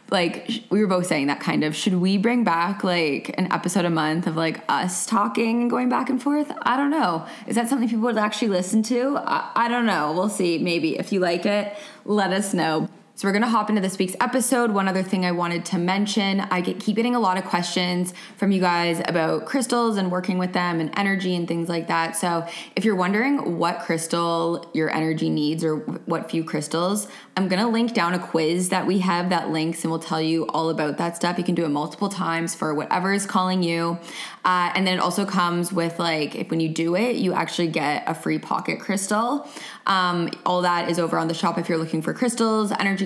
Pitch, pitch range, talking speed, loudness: 180 Hz, 170-210 Hz, 235 wpm, -23 LUFS